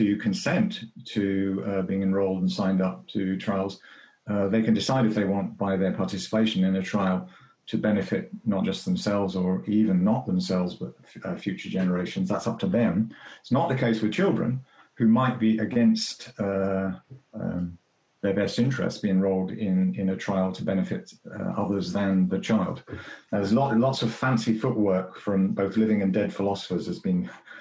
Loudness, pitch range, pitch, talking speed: -26 LUFS, 95-110 Hz, 100 Hz, 185 wpm